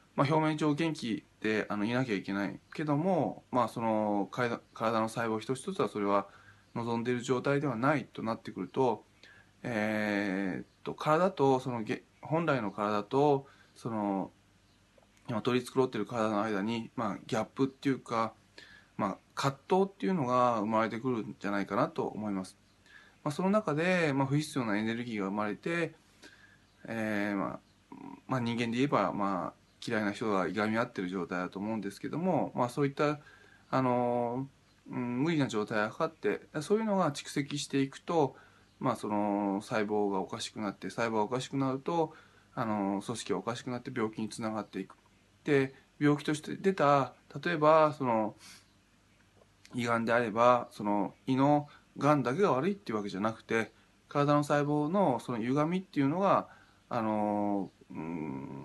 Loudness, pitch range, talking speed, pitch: -32 LUFS, 100-140 Hz, 325 characters per minute, 115 Hz